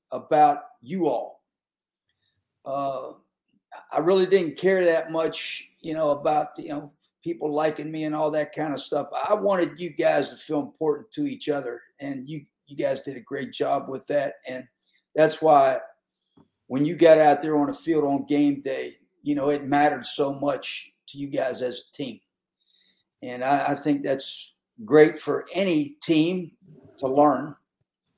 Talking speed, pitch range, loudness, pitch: 175 wpm, 140-165 Hz, -24 LUFS, 150 Hz